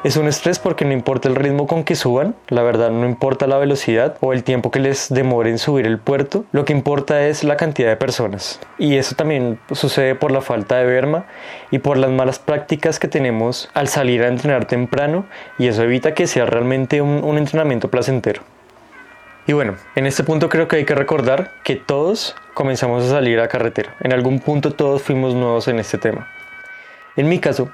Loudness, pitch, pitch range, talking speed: -17 LUFS, 135 Hz, 125-150 Hz, 205 wpm